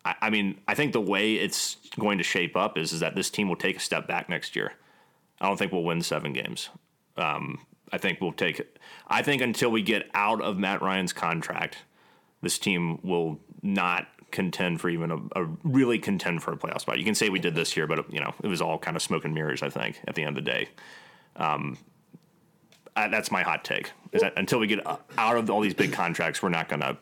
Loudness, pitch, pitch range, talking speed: -27 LUFS, 90 Hz, 85-105 Hz, 240 wpm